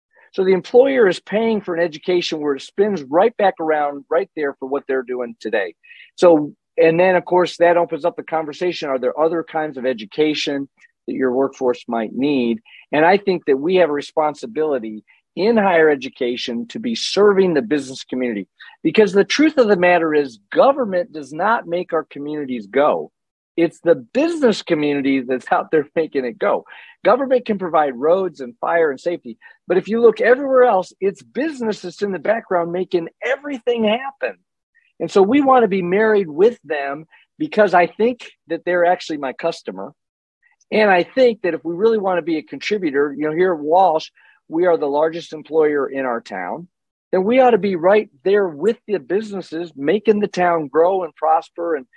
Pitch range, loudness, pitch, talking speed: 150-205 Hz, -18 LUFS, 175 Hz, 190 wpm